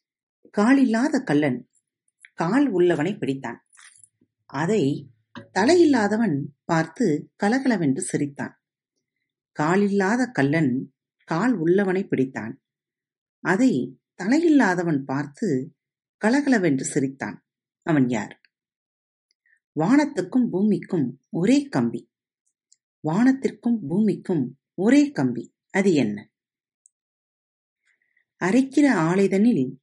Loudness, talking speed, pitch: -22 LUFS, 65 wpm, 180 Hz